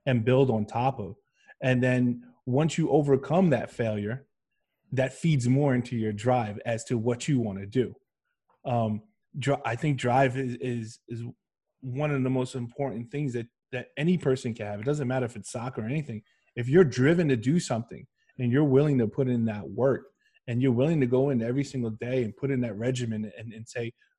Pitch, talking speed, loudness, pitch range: 125 Hz, 210 wpm, -27 LUFS, 115-135 Hz